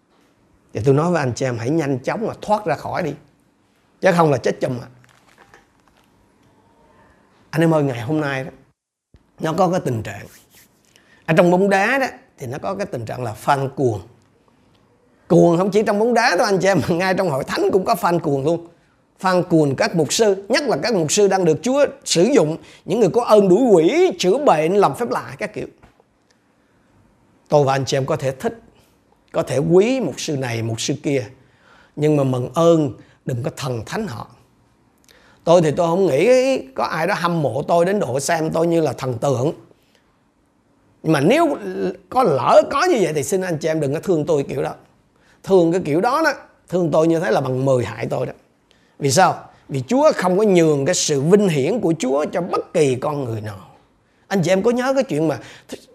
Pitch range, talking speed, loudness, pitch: 135-190 Hz, 215 wpm, -18 LUFS, 165 Hz